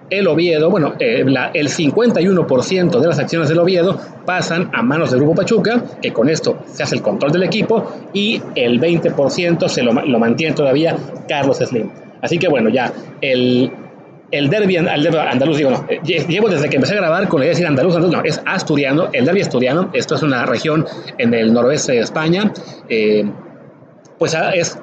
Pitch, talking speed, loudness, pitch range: 170 Hz, 195 wpm, -15 LUFS, 130-195 Hz